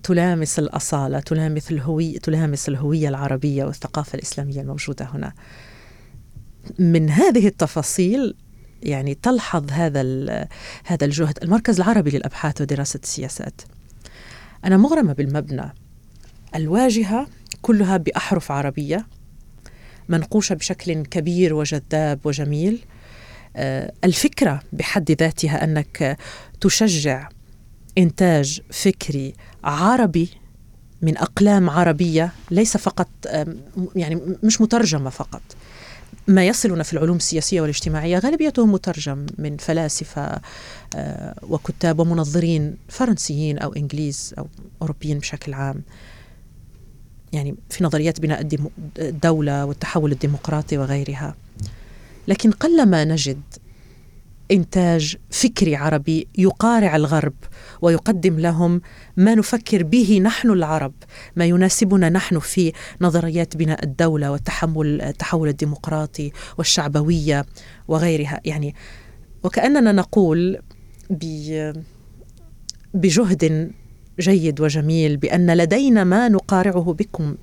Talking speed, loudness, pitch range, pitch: 90 wpm, -20 LUFS, 145-185 Hz, 160 Hz